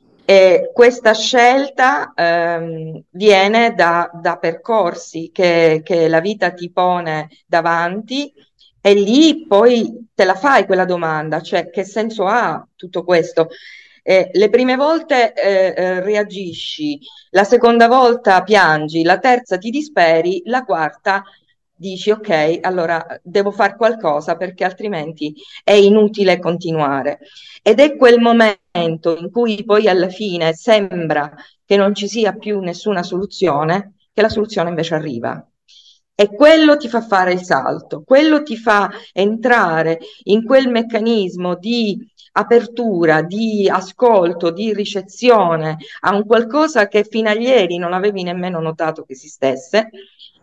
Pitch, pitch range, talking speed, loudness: 195 Hz, 170-225 Hz, 130 wpm, -15 LUFS